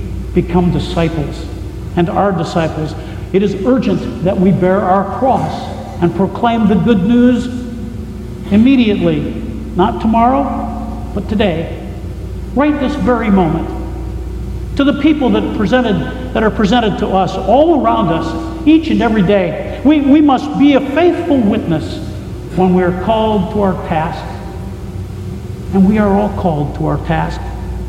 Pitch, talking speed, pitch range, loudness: 195 Hz, 140 wpm, 145-240 Hz, -14 LUFS